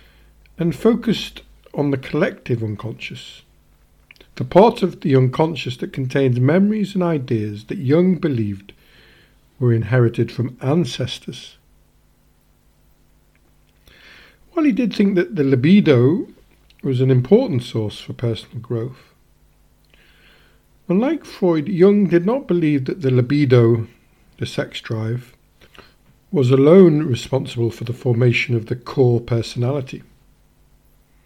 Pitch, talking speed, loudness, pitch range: 130 Hz, 115 wpm, -18 LUFS, 115-165 Hz